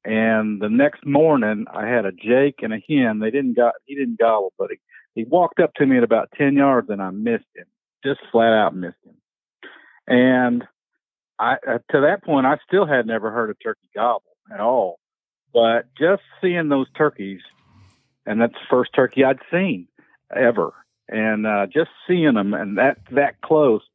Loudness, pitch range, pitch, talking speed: -19 LUFS, 110-150 Hz, 125 Hz, 185 wpm